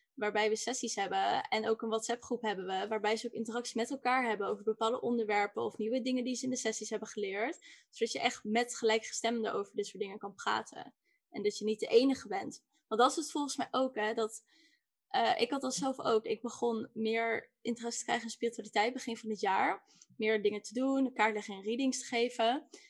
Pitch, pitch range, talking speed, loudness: 230 Hz, 215-255 Hz, 225 wpm, -34 LUFS